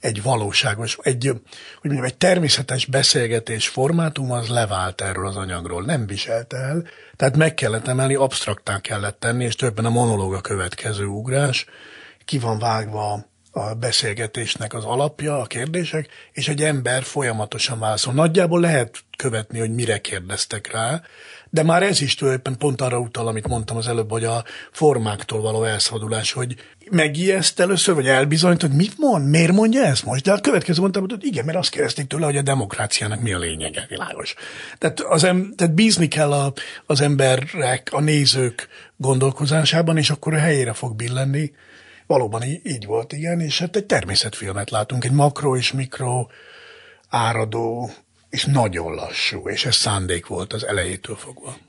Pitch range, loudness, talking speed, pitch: 115-150 Hz, -20 LUFS, 165 wpm, 130 Hz